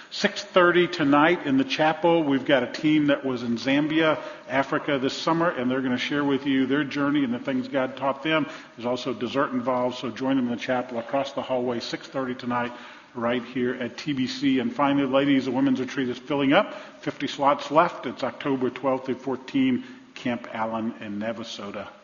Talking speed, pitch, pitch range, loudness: 200 wpm, 135 Hz, 125-150 Hz, -25 LUFS